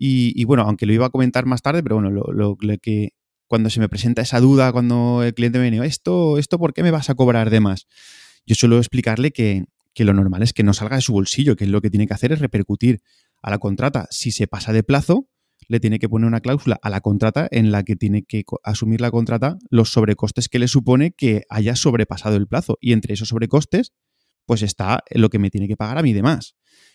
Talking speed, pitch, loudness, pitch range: 245 wpm, 115 Hz, -18 LUFS, 105-130 Hz